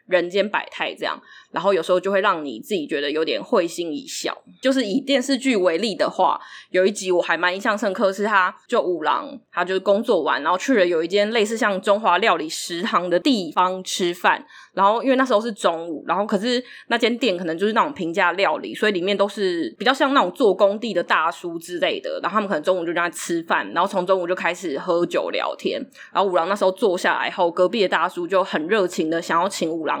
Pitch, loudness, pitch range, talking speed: 195 Hz, -21 LUFS, 175-225 Hz, 350 characters per minute